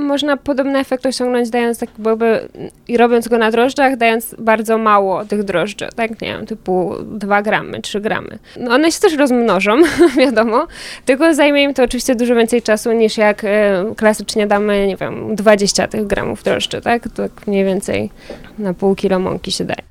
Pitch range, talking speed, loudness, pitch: 205-250 Hz, 180 wpm, -15 LUFS, 225 Hz